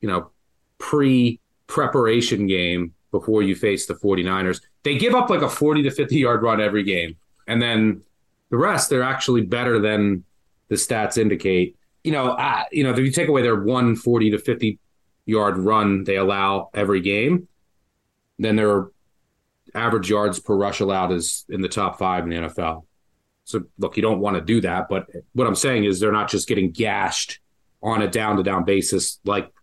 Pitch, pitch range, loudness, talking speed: 105 Hz, 95-115 Hz, -21 LUFS, 185 wpm